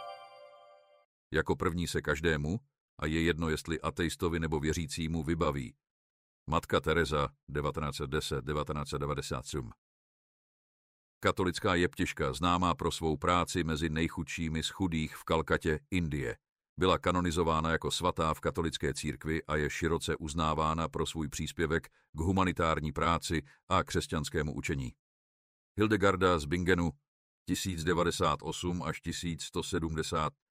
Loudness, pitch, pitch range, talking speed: -32 LUFS, 80 Hz, 75-90 Hz, 105 wpm